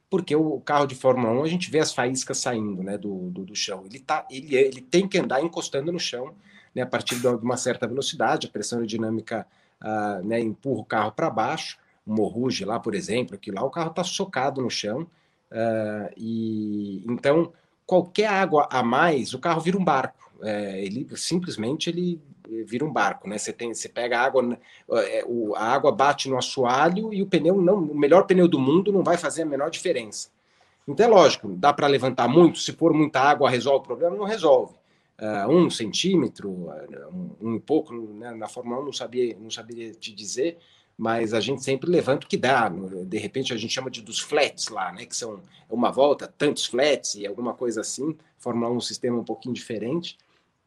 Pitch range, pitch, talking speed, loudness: 115-170 Hz, 130 Hz, 200 wpm, -24 LUFS